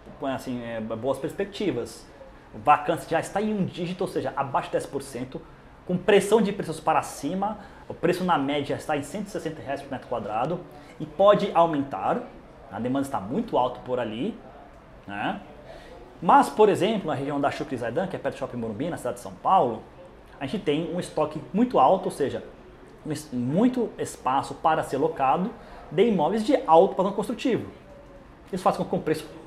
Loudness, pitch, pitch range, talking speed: -25 LUFS, 170 Hz, 150-205 Hz, 185 wpm